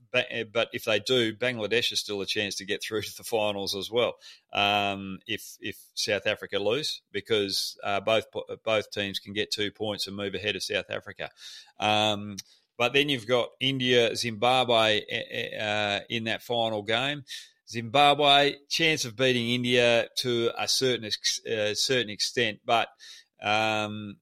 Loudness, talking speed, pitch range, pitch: -26 LUFS, 155 wpm, 105-125 Hz, 110 Hz